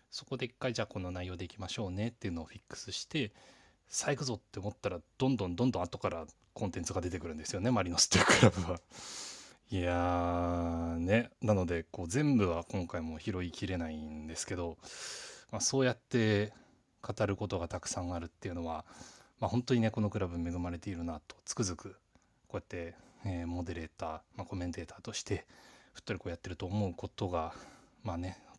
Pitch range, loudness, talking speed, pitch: 85-110 Hz, -35 LUFS, 410 characters per minute, 95 Hz